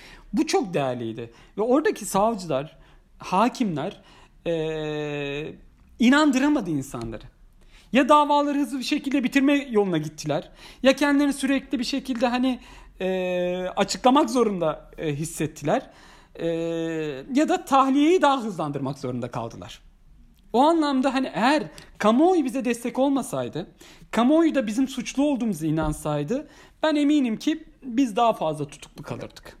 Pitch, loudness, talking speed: 220 Hz, -23 LUFS, 120 wpm